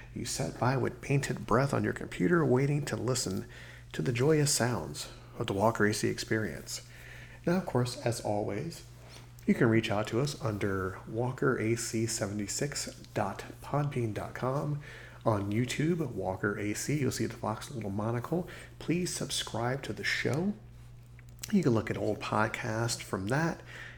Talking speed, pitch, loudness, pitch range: 145 wpm, 120 Hz, -32 LUFS, 110-135 Hz